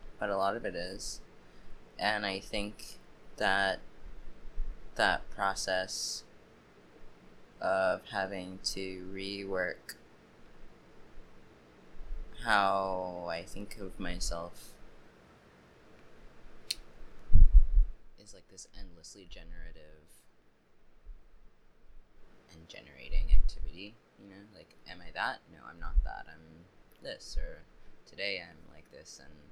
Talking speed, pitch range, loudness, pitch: 95 wpm, 75-95 Hz, -34 LUFS, 90 Hz